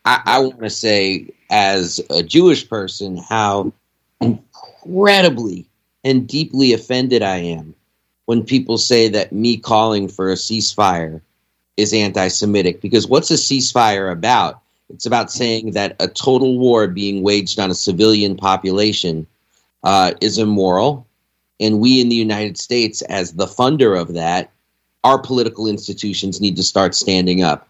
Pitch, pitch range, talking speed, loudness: 105 Hz, 95-120 Hz, 145 wpm, -16 LUFS